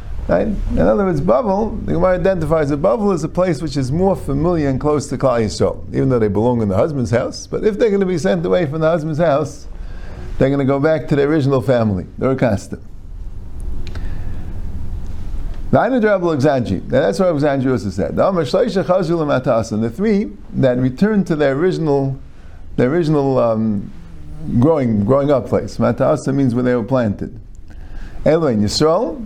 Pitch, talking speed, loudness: 130 Hz, 160 wpm, -17 LUFS